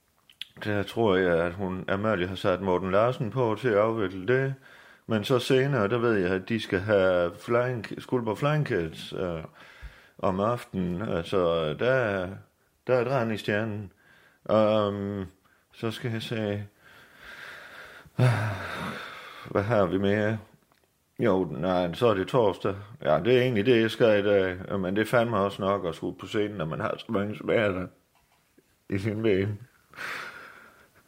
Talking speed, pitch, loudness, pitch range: 160 wpm, 105 Hz, -27 LUFS, 95-120 Hz